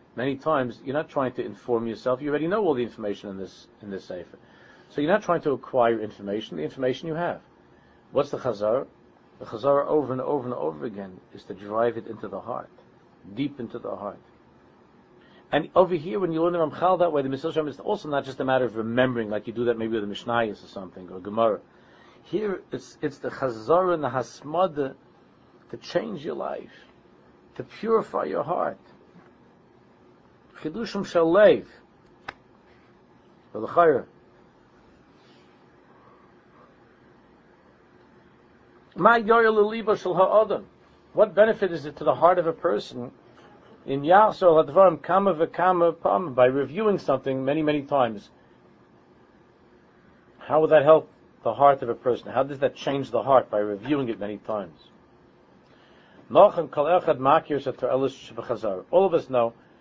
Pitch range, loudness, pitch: 115-170 Hz, -24 LUFS, 140 Hz